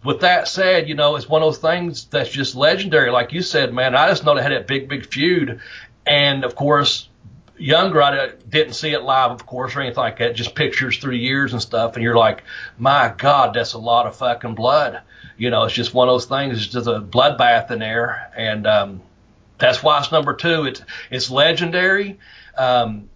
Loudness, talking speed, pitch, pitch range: -17 LUFS, 215 wpm, 130 Hz, 120-150 Hz